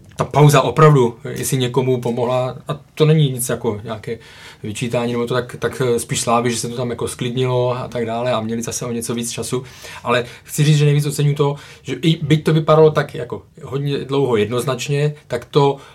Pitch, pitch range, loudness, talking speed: 130 Hz, 120-145 Hz, -18 LUFS, 205 wpm